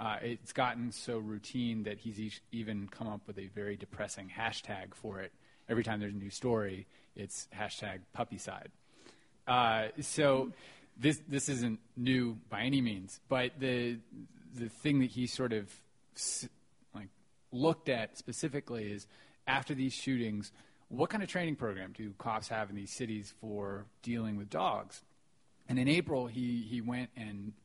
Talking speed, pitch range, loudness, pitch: 170 wpm, 105-130 Hz, -37 LUFS, 115 Hz